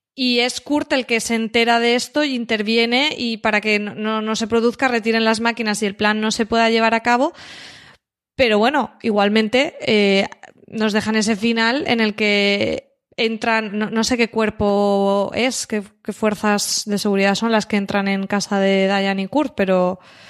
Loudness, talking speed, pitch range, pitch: -18 LUFS, 190 wpm, 205-235 Hz, 220 Hz